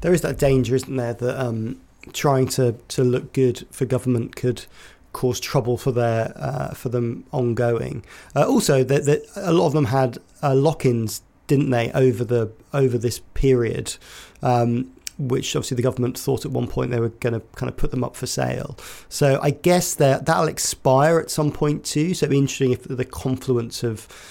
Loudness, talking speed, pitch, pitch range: -22 LUFS, 195 wpm, 130 Hz, 120-140 Hz